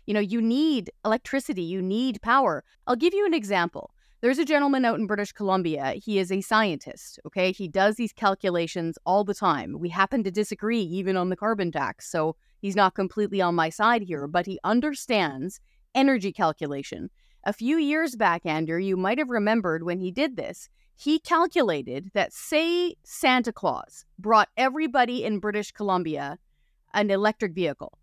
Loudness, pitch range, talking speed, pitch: -25 LUFS, 180-245 Hz, 175 wpm, 210 Hz